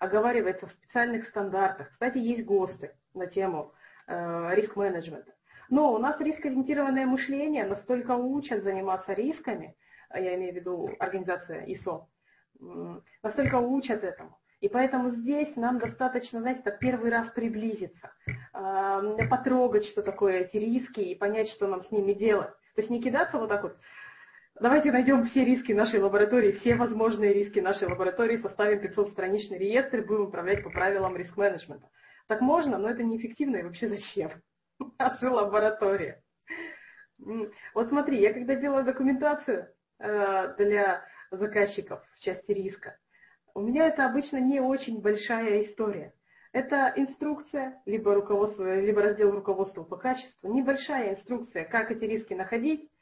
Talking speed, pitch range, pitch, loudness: 145 wpm, 195-255 Hz, 215 Hz, -28 LUFS